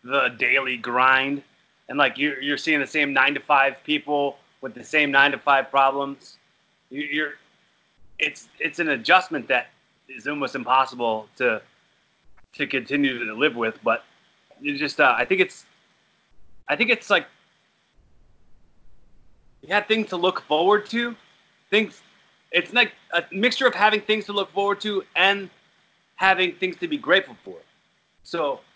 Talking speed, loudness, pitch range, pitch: 155 wpm, -22 LUFS, 140-210 Hz, 155 Hz